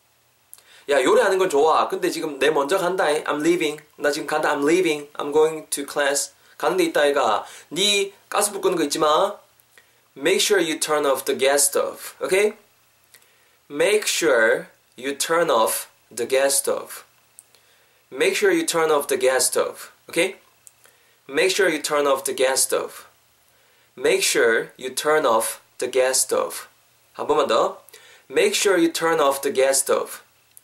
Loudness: -20 LUFS